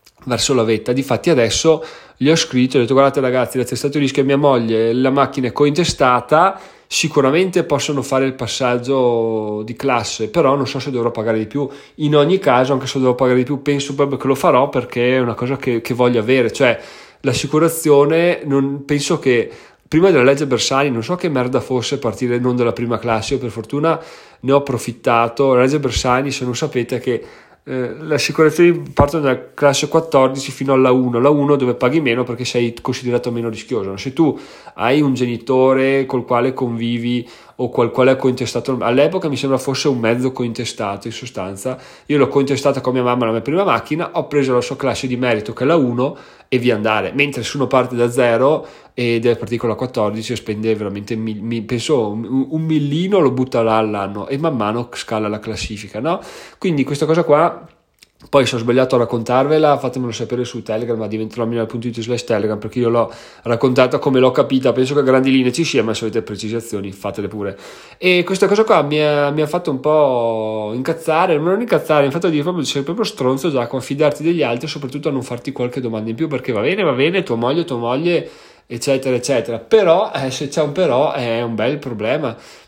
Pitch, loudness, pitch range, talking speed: 130 Hz, -17 LUFS, 120-145 Hz, 210 wpm